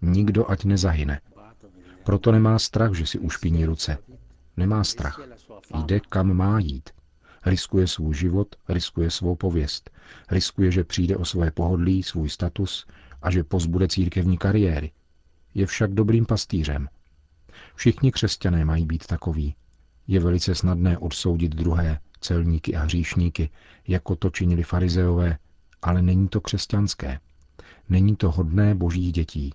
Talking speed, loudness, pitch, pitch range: 130 wpm, -23 LUFS, 90 Hz, 80-95 Hz